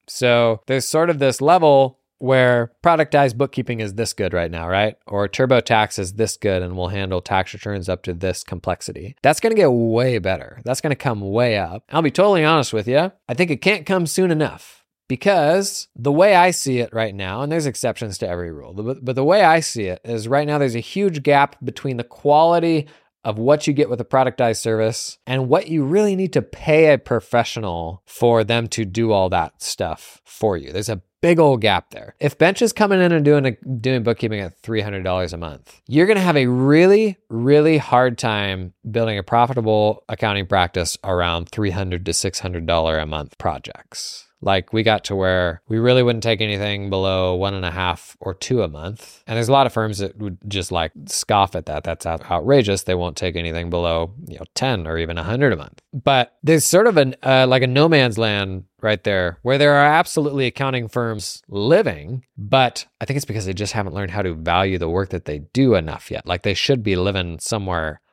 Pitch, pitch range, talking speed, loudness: 115 Hz, 95-140 Hz, 215 wpm, -19 LUFS